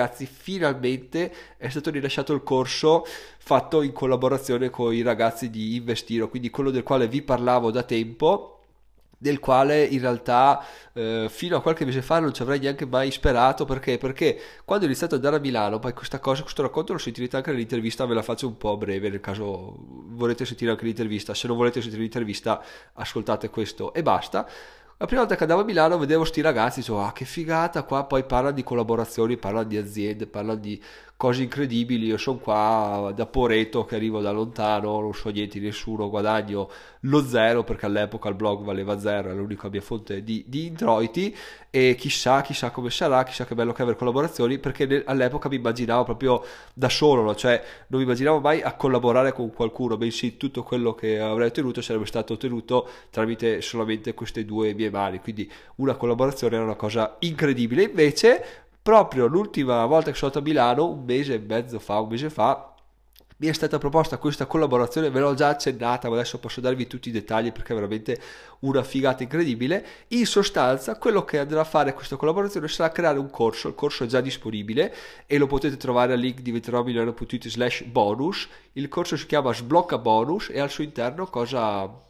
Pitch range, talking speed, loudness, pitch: 115-140 Hz, 190 wpm, -24 LUFS, 125 Hz